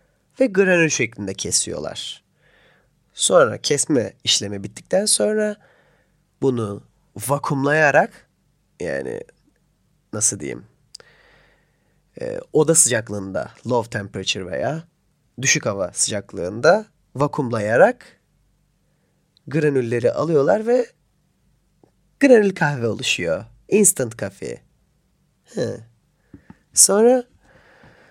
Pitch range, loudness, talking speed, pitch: 115-190 Hz, -19 LUFS, 70 wpm, 145 Hz